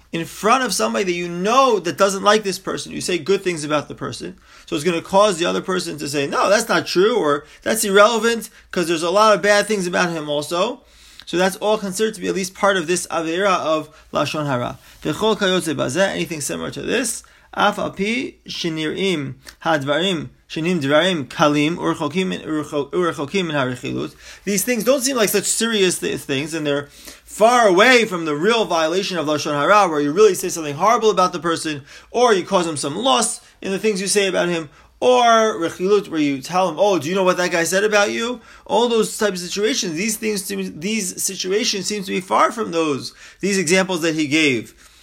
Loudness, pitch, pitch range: -19 LUFS, 185 Hz, 160-210 Hz